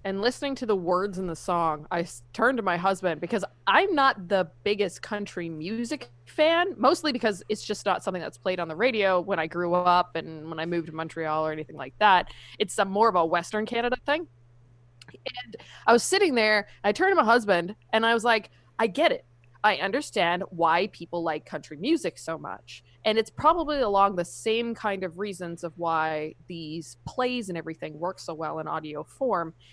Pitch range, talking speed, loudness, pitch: 160-225 Hz, 200 wpm, -26 LUFS, 180 Hz